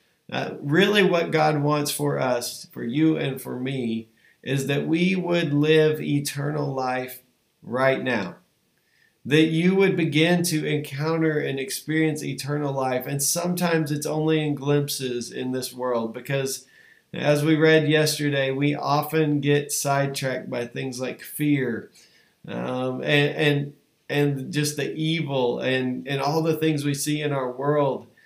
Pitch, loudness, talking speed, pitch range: 145 Hz, -23 LUFS, 150 wpm, 135-155 Hz